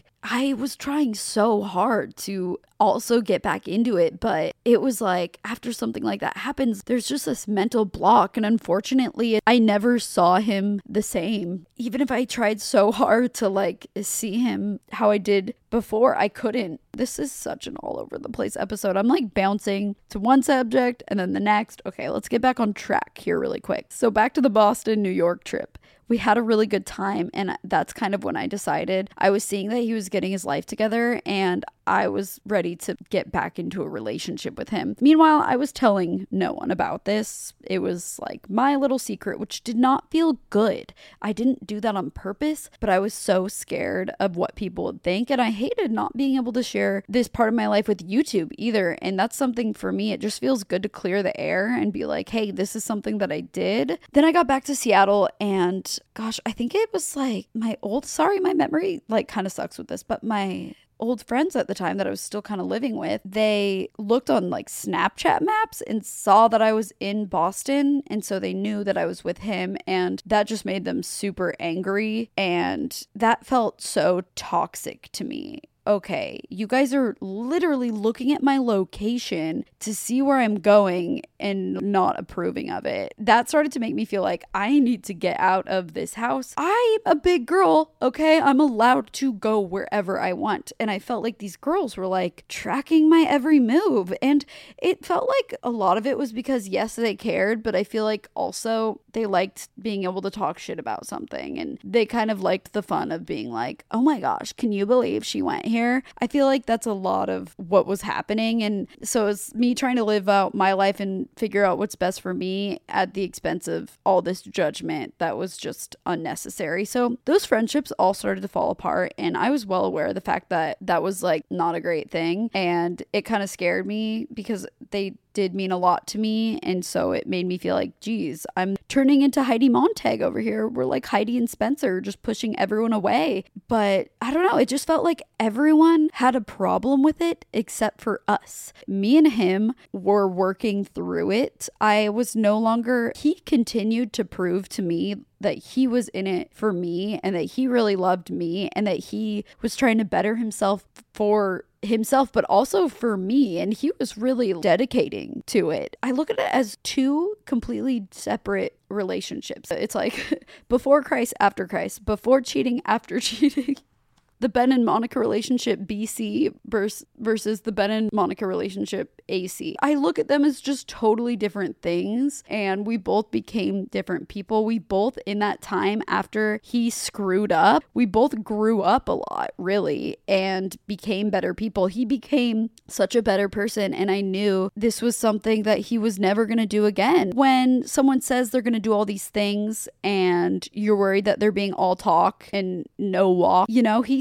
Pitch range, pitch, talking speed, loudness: 200-255 Hz, 220 Hz, 200 wpm, -23 LUFS